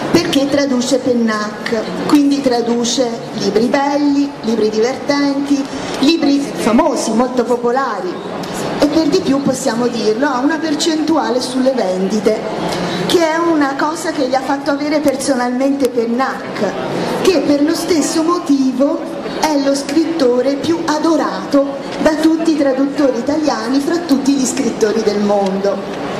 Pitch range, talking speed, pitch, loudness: 245-300 Hz, 130 wpm, 275 Hz, -15 LUFS